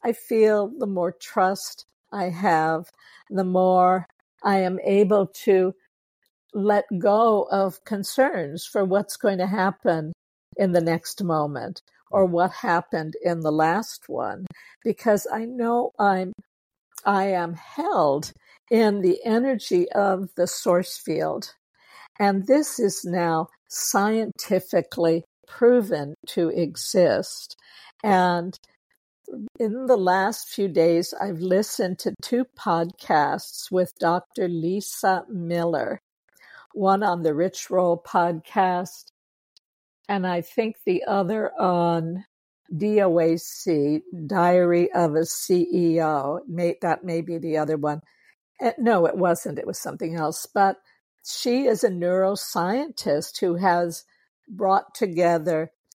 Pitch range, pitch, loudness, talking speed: 170-210 Hz, 185 Hz, -23 LUFS, 115 wpm